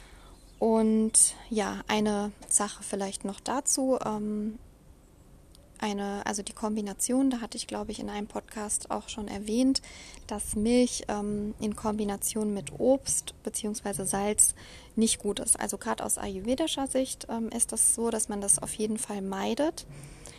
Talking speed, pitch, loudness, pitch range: 150 wpm, 215 Hz, -28 LUFS, 205-240 Hz